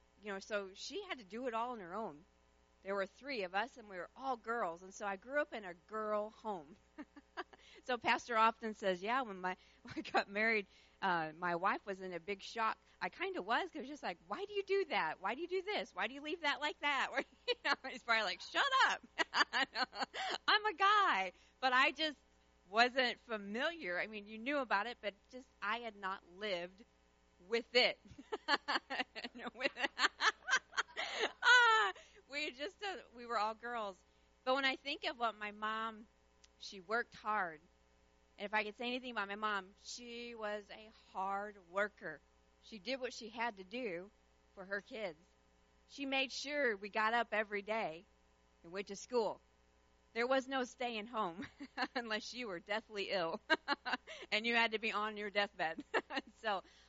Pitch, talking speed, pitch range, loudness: 220 Hz, 190 wpm, 200-260 Hz, -38 LUFS